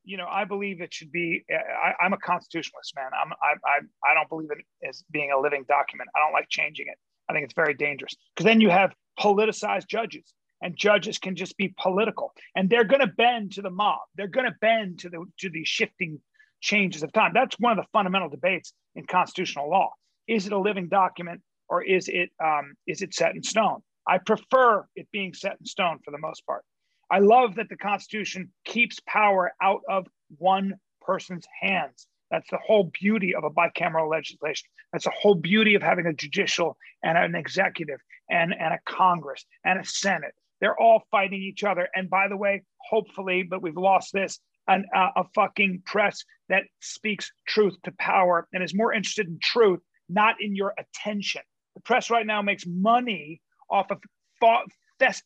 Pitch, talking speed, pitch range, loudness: 195 Hz, 195 wpm, 175-215 Hz, -24 LUFS